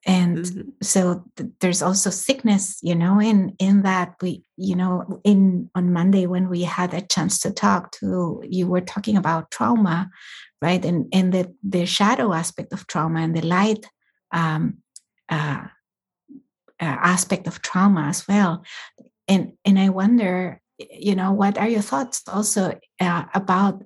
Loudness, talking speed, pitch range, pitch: -21 LUFS, 160 wpm, 180-200 Hz, 190 Hz